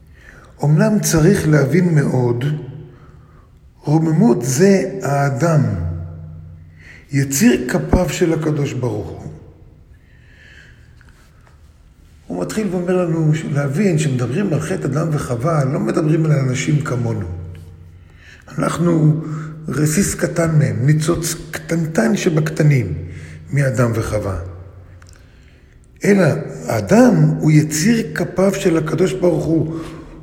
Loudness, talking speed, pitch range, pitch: -17 LUFS, 90 wpm, 100-165 Hz, 150 Hz